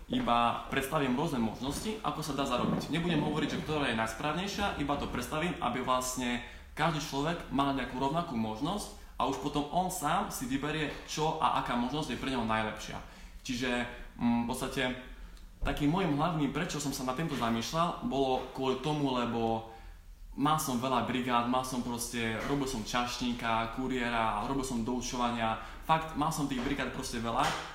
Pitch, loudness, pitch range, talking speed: 130 Hz, -33 LUFS, 120-150 Hz, 165 wpm